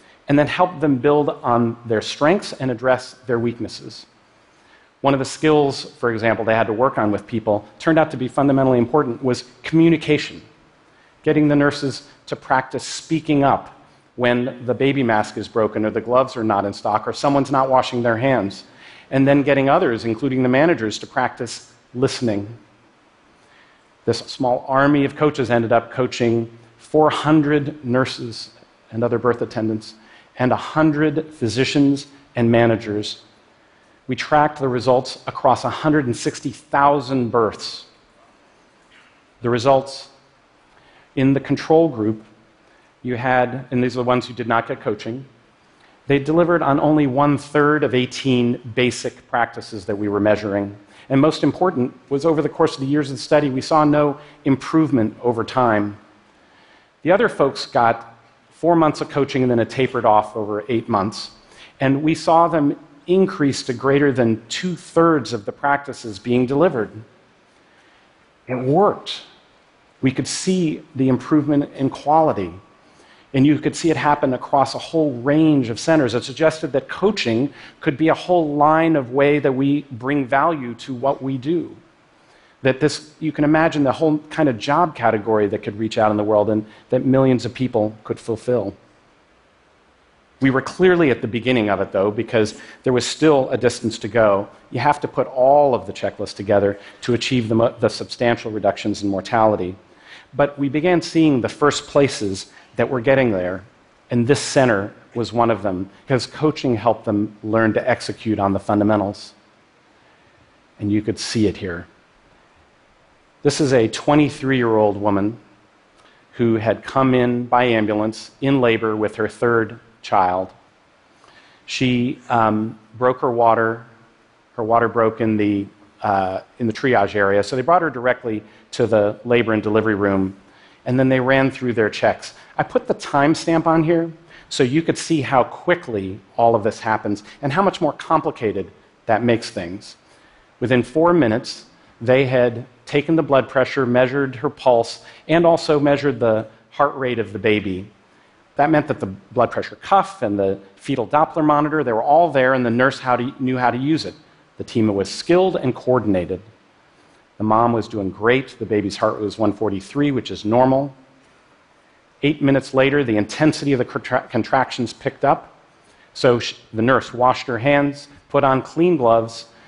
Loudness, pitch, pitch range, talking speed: -19 LUFS, 125 Hz, 110-145 Hz, 165 wpm